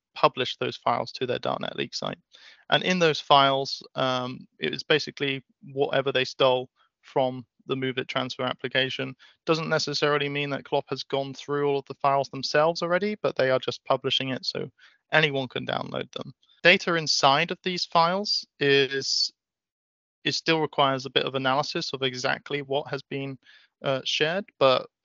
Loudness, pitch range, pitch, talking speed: -25 LUFS, 135-155 Hz, 140 Hz, 170 wpm